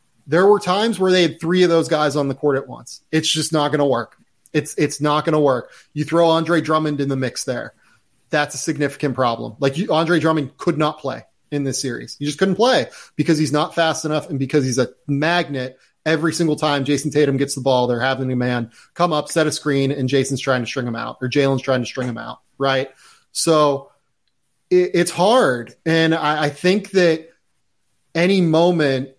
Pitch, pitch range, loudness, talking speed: 150 Hz, 135-165 Hz, -19 LUFS, 220 wpm